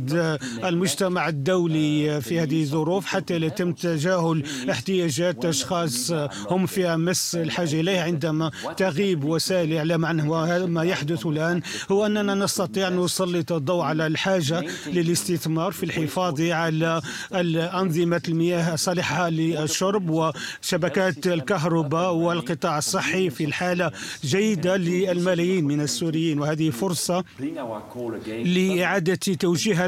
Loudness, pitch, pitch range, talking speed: -24 LUFS, 170 Hz, 160-185 Hz, 110 wpm